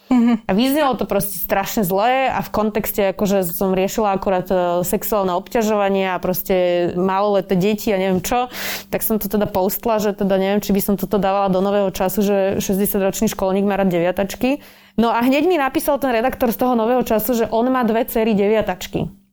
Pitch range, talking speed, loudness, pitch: 195-225 Hz, 190 wpm, -18 LUFS, 205 Hz